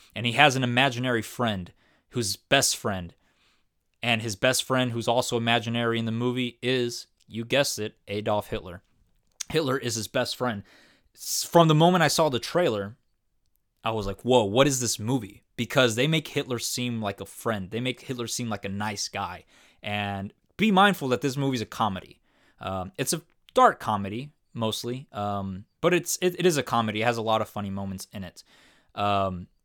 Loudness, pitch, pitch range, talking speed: -26 LUFS, 120 Hz, 105-130 Hz, 190 wpm